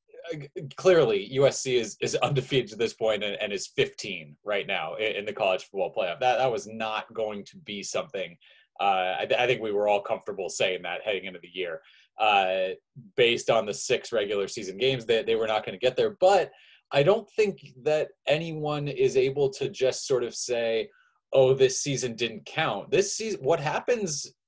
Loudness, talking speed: -26 LUFS, 200 wpm